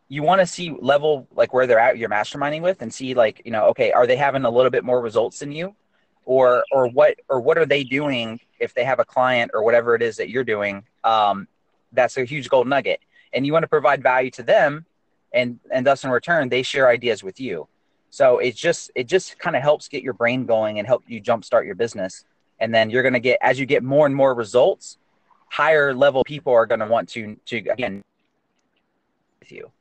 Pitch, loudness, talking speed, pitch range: 135 Hz, -20 LUFS, 230 wpm, 120-155 Hz